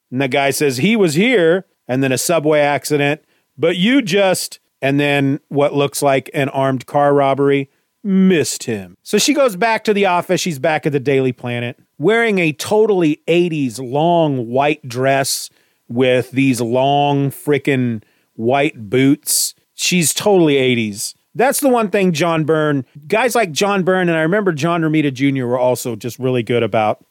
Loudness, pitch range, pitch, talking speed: -16 LUFS, 130-175 Hz, 145 Hz, 170 wpm